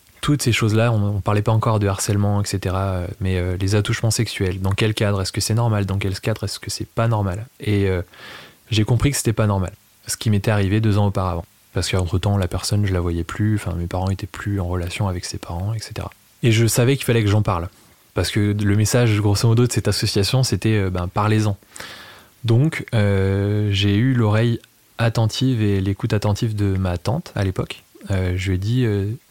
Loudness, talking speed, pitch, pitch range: -20 LUFS, 215 wpm, 105 Hz, 95-115 Hz